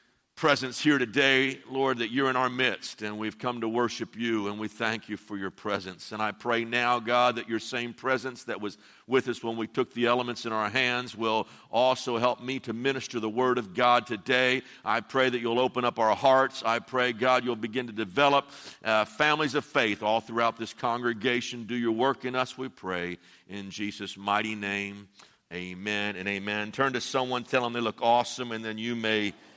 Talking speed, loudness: 210 wpm, -28 LUFS